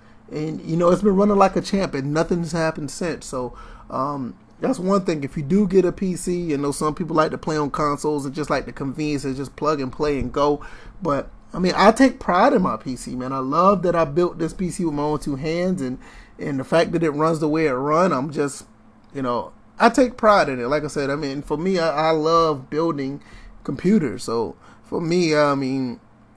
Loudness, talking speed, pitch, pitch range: -21 LUFS, 235 wpm, 155 Hz, 140-175 Hz